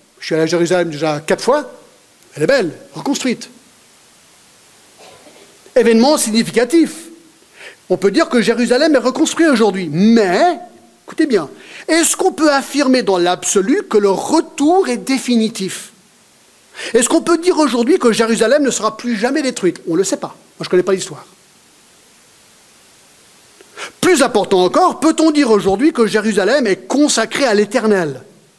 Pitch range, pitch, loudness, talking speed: 200-315 Hz, 240 Hz, -14 LUFS, 150 wpm